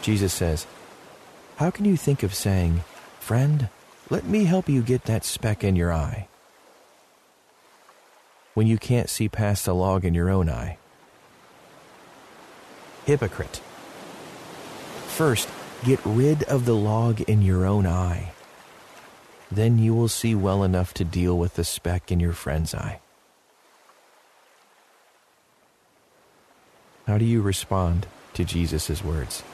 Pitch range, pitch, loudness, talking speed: 90-115 Hz, 100 Hz, -24 LUFS, 130 wpm